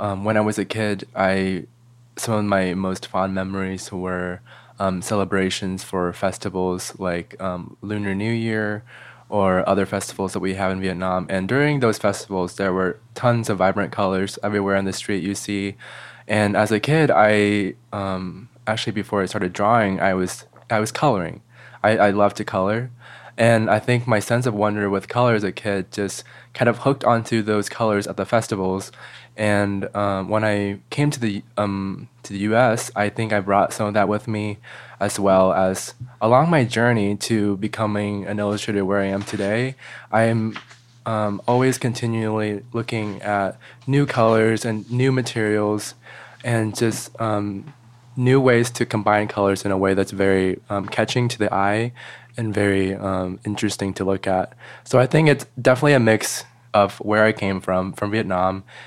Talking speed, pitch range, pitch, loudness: 175 wpm, 95-115 Hz, 105 Hz, -21 LUFS